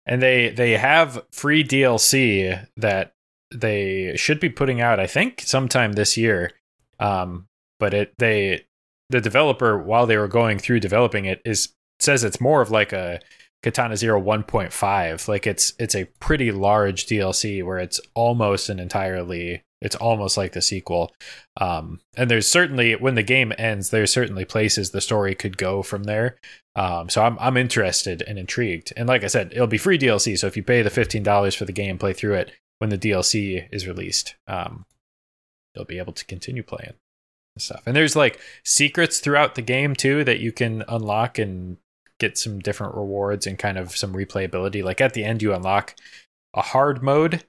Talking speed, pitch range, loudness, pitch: 185 wpm, 95-125 Hz, -21 LUFS, 105 Hz